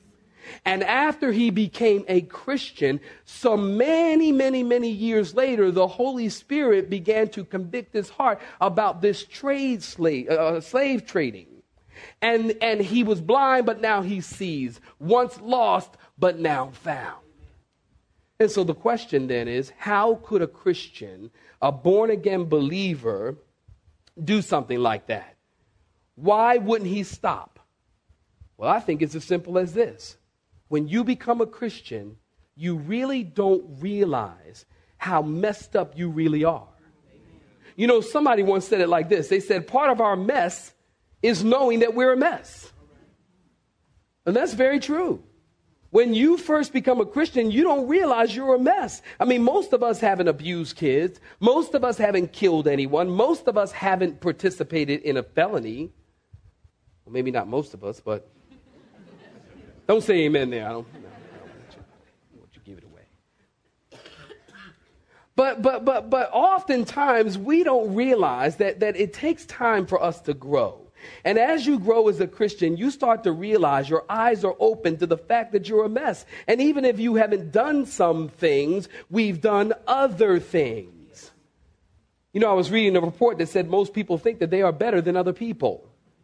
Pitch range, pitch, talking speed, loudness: 170-250 Hz, 215 Hz, 165 wpm, -23 LUFS